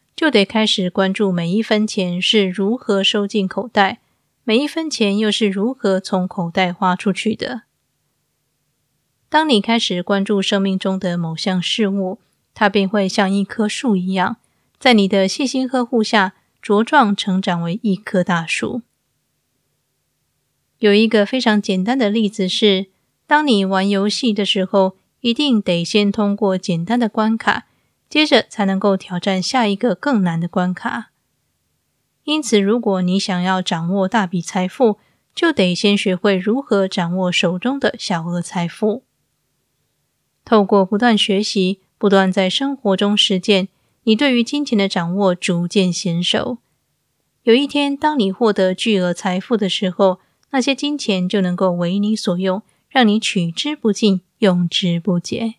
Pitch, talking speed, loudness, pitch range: 200 Hz, 225 characters per minute, -17 LUFS, 185-225 Hz